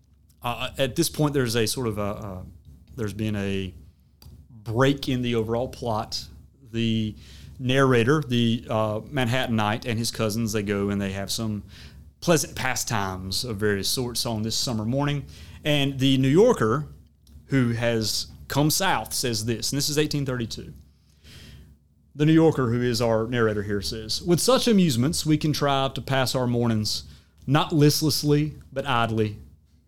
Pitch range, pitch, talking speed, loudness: 100-135 Hz, 115 Hz, 155 wpm, -24 LUFS